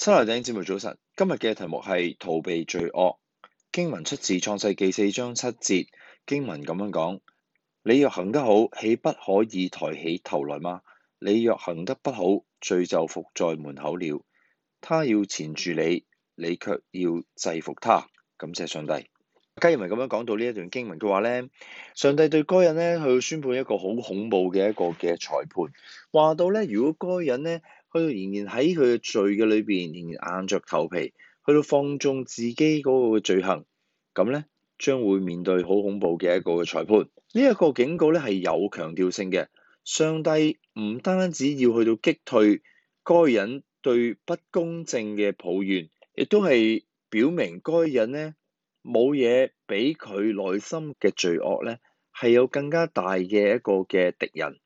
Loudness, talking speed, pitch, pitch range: -25 LUFS, 245 characters per minute, 120 Hz, 95-160 Hz